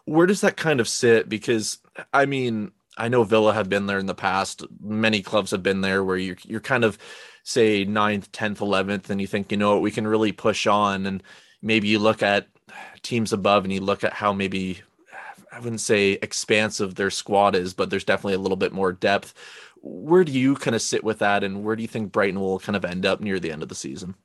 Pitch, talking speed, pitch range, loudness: 105 Hz, 240 wpm, 100-110 Hz, -22 LUFS